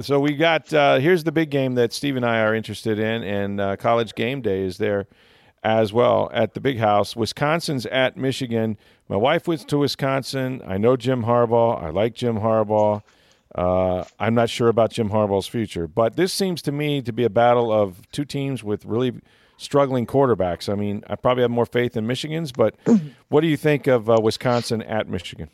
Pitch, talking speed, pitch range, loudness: 120 Hz, 205 wpm, 110-140 Hz, -21 LUFS